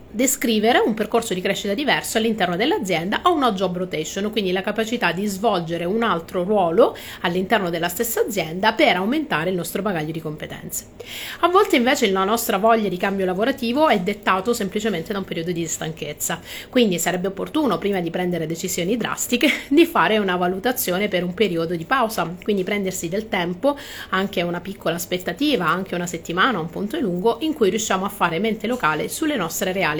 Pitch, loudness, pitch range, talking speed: 200 Hz, -21 LUFS, 175-230 Hz, 180 wpm